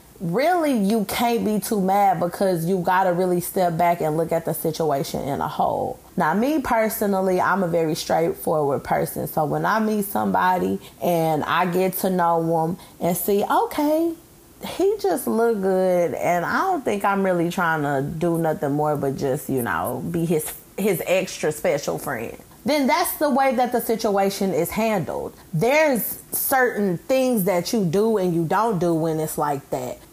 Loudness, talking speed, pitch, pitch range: -22 LUFS, 180 wpm, 190 Hz, 165-230 Hz